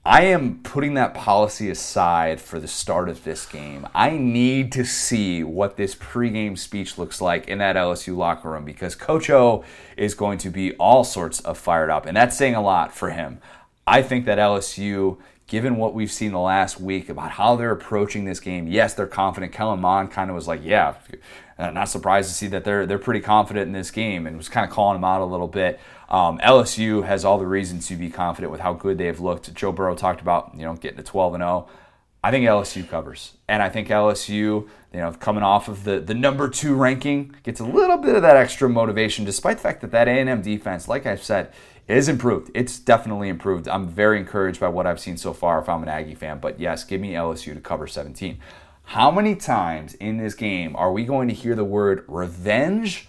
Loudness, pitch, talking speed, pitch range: -21 LUFS, 100 Hz, 225 wpm, 90-115 Hz